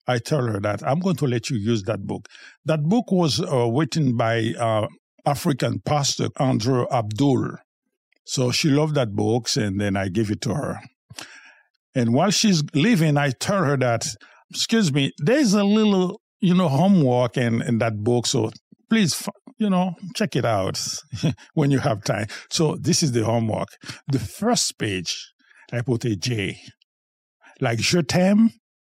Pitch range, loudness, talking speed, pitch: 115-170 Hz, -22 LUFS, 170 wpm, 135 Hz